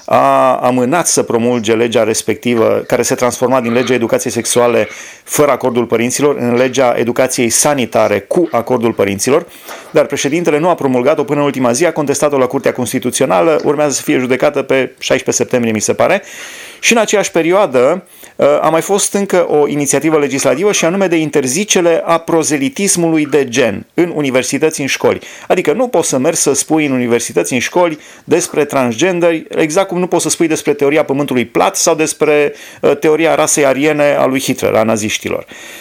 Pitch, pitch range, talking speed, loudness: 145 Hz, 125-160 Hz, 175 wpm, -12 LUFS